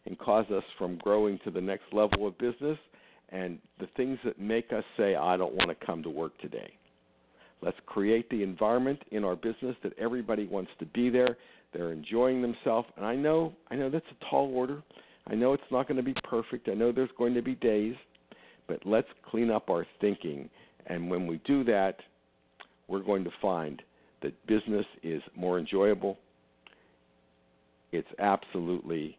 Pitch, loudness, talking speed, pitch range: 105 Hz, -31 LUFS, 180 wpm, 85-120 Hz